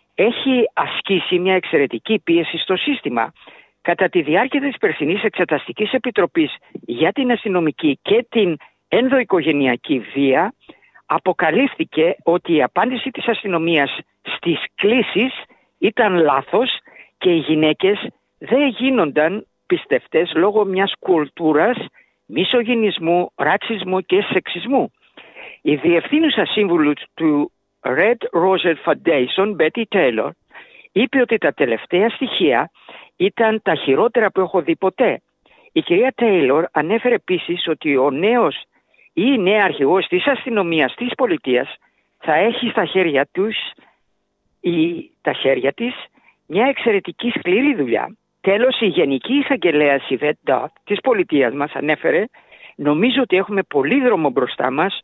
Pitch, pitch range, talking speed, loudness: 200 Hz, 165-255 Hz, 120 wpm, -18 LUFS